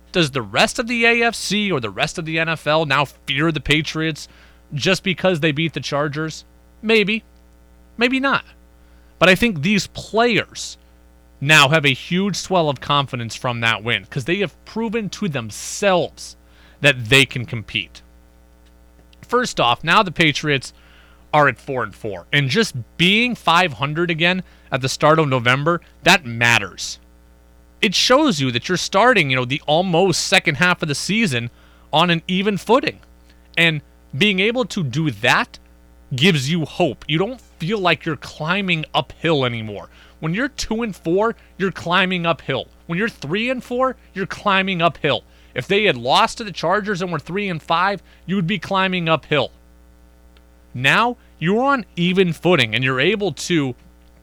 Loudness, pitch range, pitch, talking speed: -18 LUFS, 115-190 Hz, 155 Hz, 165 wpm